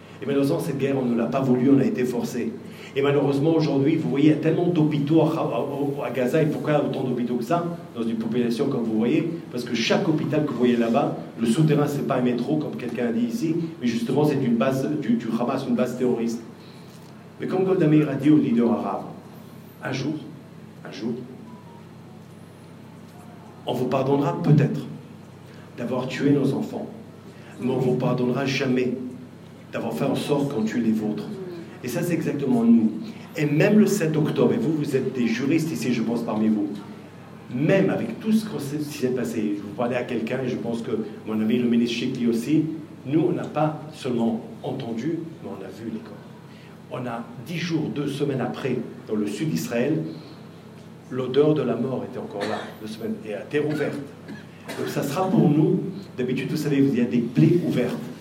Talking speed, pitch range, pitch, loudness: 205 wpm, 120-155 Hz, 140 Hz, -24 LUFS